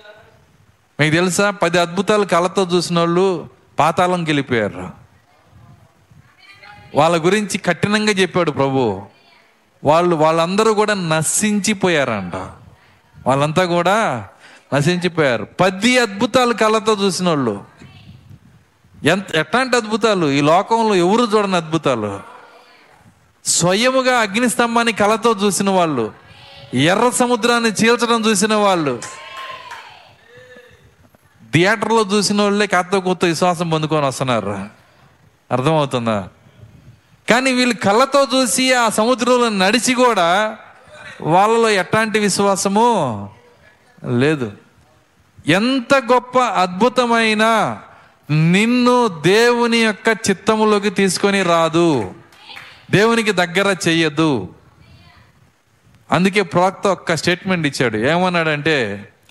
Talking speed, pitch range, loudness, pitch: 85 wpm, 155-220 Hz, -16 LUFS, 190 Hz